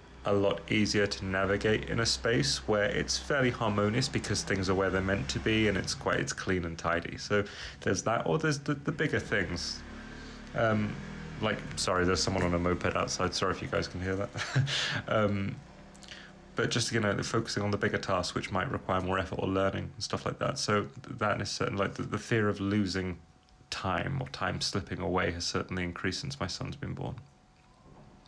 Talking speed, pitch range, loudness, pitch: 205 wpm, 95-115 Hz, -31 LUFS, 100 Hz